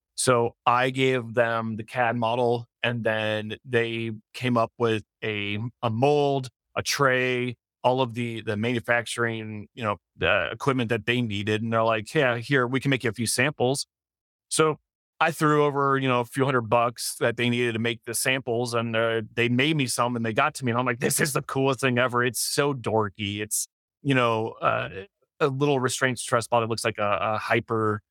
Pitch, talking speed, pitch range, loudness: 120 Hz, 205 wpm, 115-130 Hz, -25 LUFS